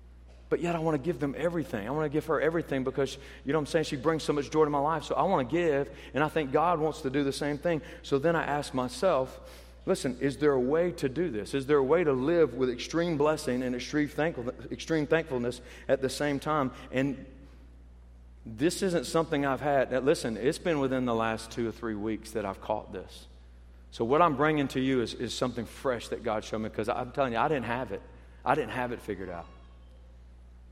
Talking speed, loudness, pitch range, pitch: 240 wpm, -30 LUFS, 110-155 Hz, 135 Hz